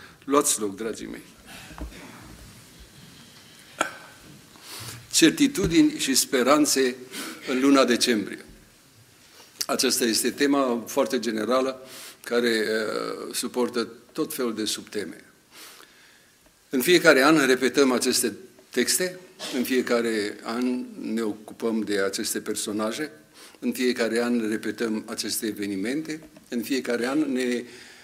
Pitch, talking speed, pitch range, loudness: 125 Hz, 100 wpm, 110-135 Hz, -24 LUFS